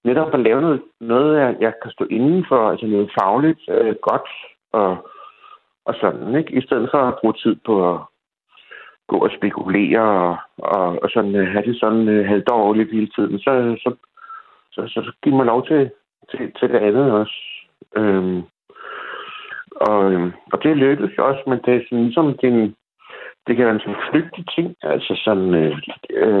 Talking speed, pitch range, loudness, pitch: 175 wpm, 105-145 Hz, -18 LUFS, 120 Hz